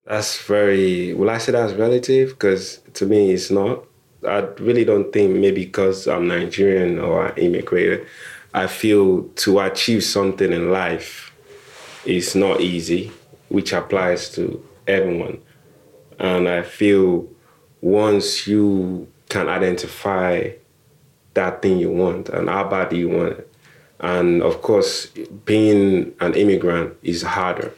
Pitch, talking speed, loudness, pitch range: 95 Hz, 135 wpm, -19 LUFS, 90-105 Hz